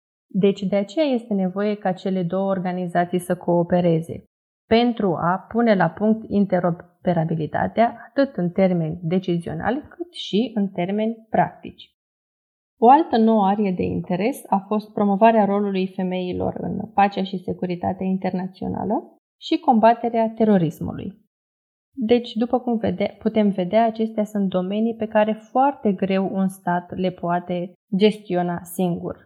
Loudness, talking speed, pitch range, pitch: -21 LUFS, 130 wpm, 180-225 Hz, 200 Hz